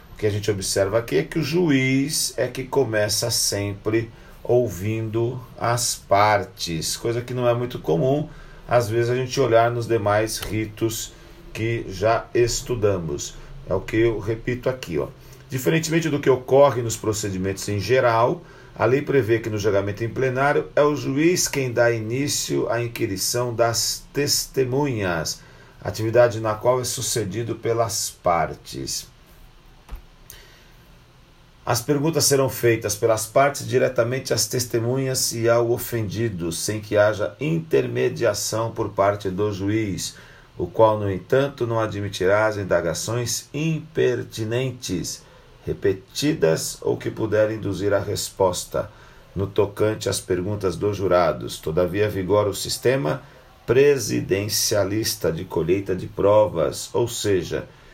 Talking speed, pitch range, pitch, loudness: 130 wpm, 105-130 Hz, 115 Hz, -22 LUFS